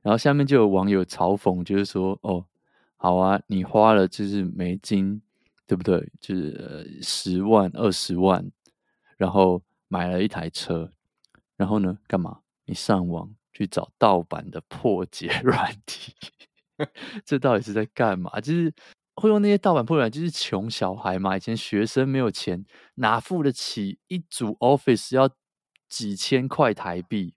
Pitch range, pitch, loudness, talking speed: 95-135 Hz, 105 Hz, -24 LUFS, 235 characters per minute